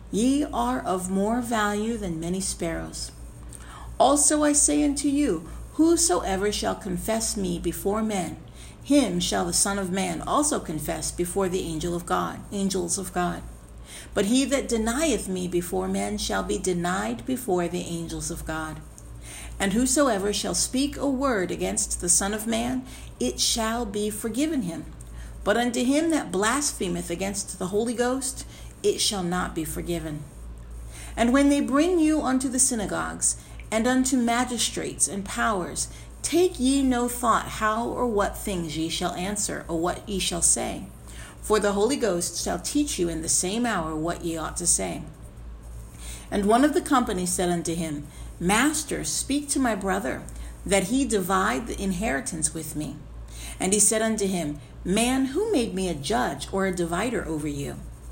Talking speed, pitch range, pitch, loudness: 165 wpm, 165-240 Hz, 195 Hz, -25 LUFS